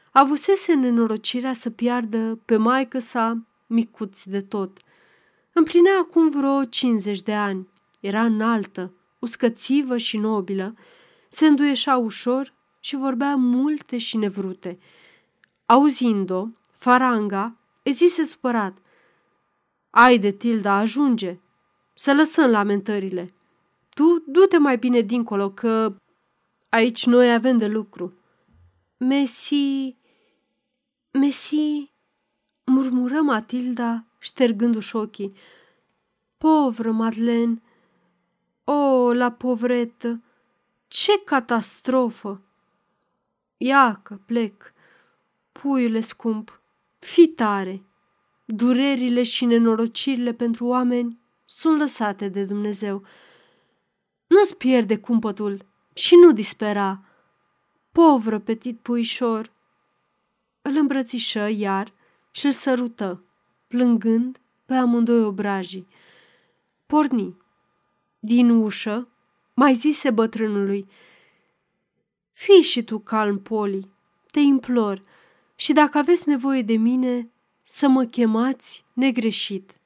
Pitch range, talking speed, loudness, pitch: 215-270 Hz, 90 wpm, -20 LUFS, 235 Hz